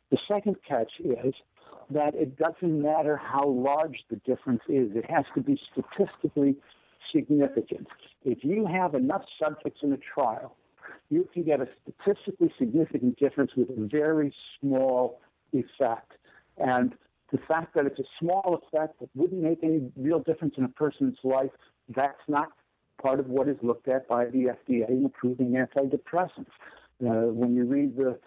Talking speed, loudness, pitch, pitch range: 160 wpm, -28 LUFS, 140 Hz, 130-160 Hz